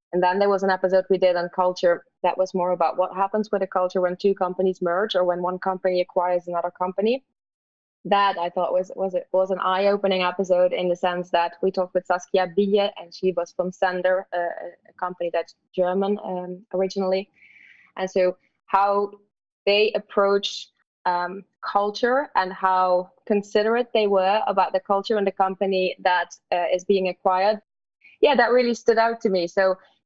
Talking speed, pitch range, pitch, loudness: 185 wpm, 180-200 Hz, 185 Hz, -23 LUFS